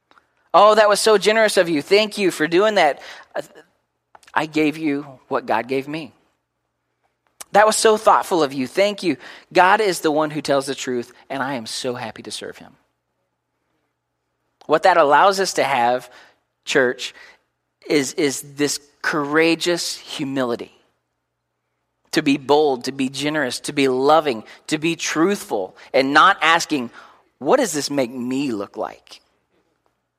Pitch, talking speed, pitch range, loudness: 145 Hz, 155 wpm, 125-165 Hz, -18 LUFS